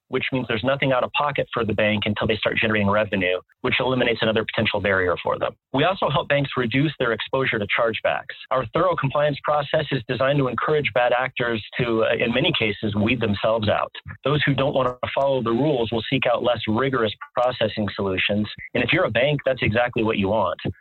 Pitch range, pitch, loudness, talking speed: 110-135 Hz, 120 Hz, -22 LUFS, 215 wpm